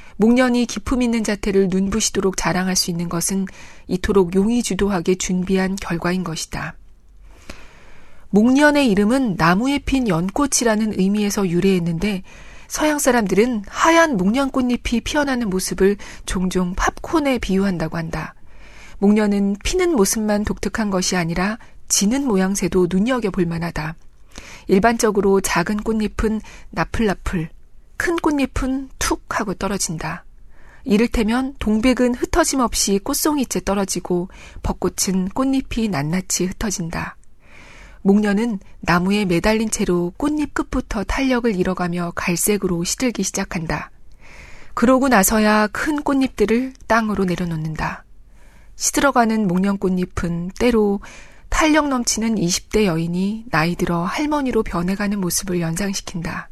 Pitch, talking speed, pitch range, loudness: 205 Hz, 295 characters per minute, 185-240 Hz, -19 LUFS